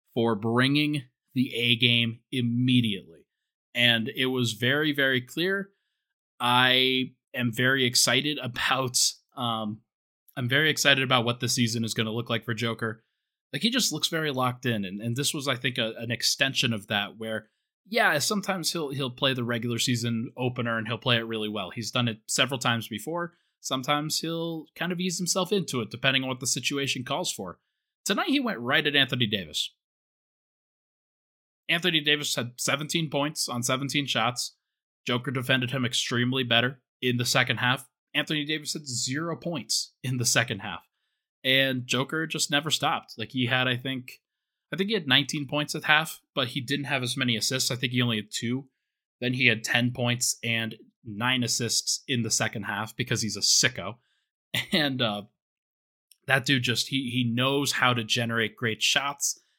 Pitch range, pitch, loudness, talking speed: 120-145 Hz, 130 Hz, -26 LUFS, 180 wpm